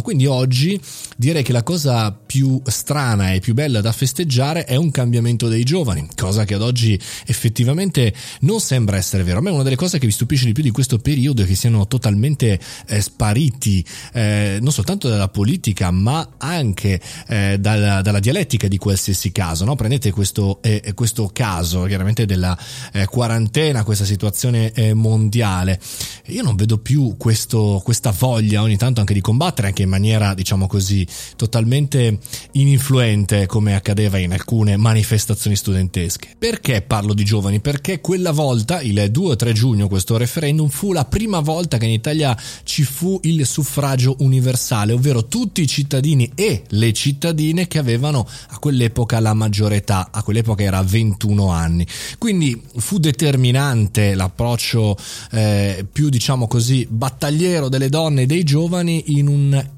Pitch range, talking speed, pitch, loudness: 105-140 Hz, 160 wpm, 115 Hz, -17 LUFS